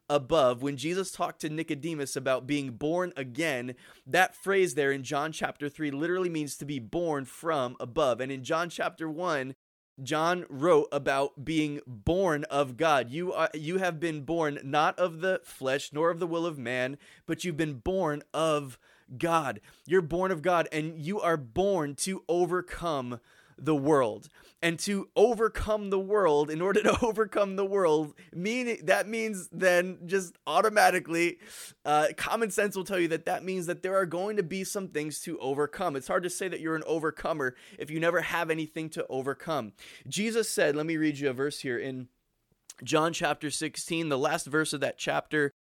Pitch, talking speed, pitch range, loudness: 160 Hz, 185 wpm, 145-180 Hz, -29 LUFS